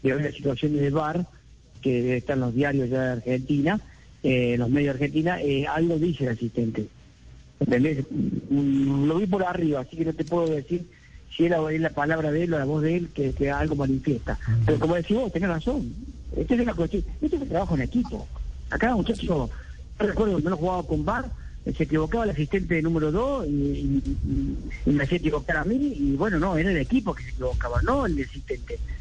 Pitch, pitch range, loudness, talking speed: 150 Hz, 135-175 Hz, -25 LUFS, 220 wpm